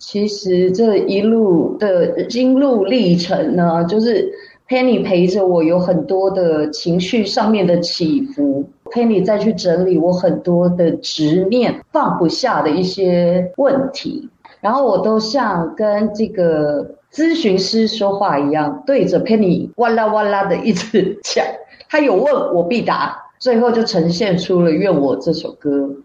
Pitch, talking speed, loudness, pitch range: 200 Hz, 235 characters per minute, -15 LUFS, 175-235 Hz